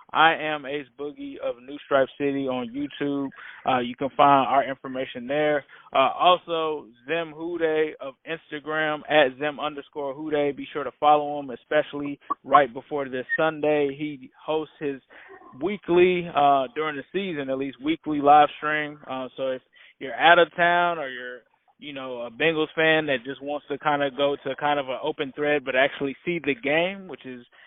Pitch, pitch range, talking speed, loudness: 145 Hz, 140-155 Hz, 180 wpm, -24 LUFS